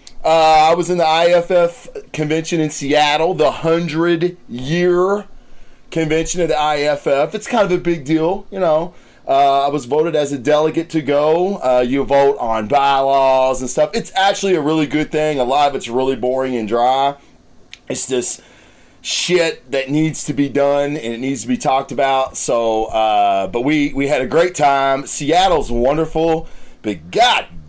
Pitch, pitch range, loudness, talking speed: 150 Hz, 135-165 Hz, -16 LUFS, 175 wpm